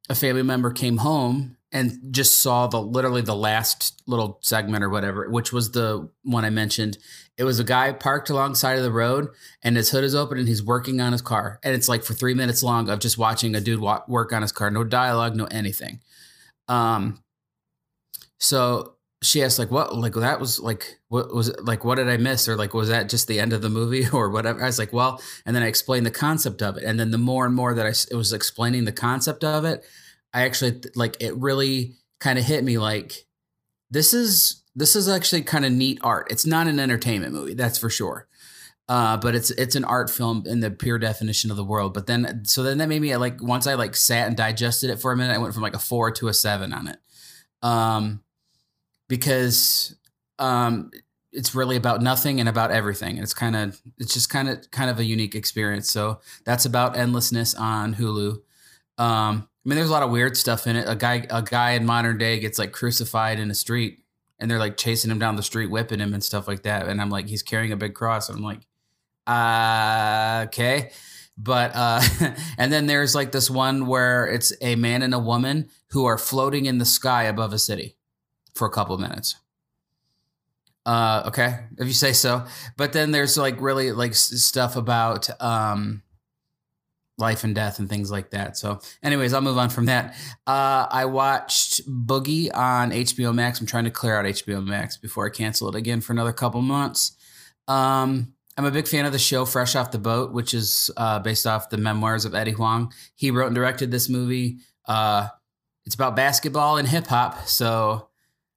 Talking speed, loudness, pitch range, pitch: 215 wpm, -22 LUFS, 110-130 Hz, 120 Hz